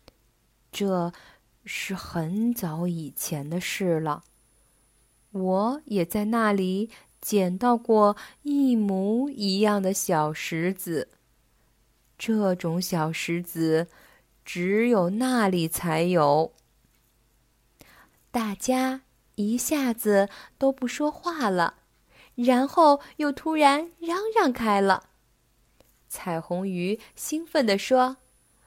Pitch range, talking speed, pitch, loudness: 170-245 Hz, 130 characters per minute, 200 Hz, -25 LUFS